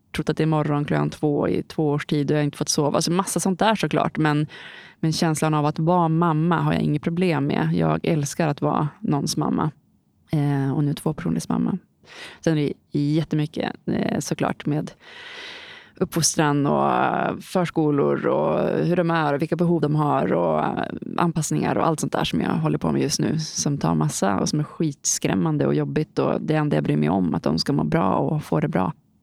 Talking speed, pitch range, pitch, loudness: 215 wpm, 145-170 Hz, 155 Hz, -22 LUFS